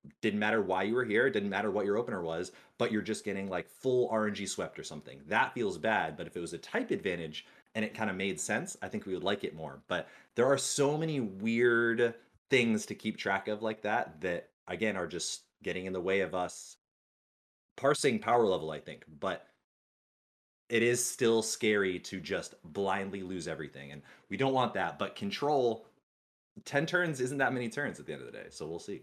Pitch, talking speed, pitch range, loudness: 110 Hz, 215 wpm, 95-125 Hz, -33 LUFS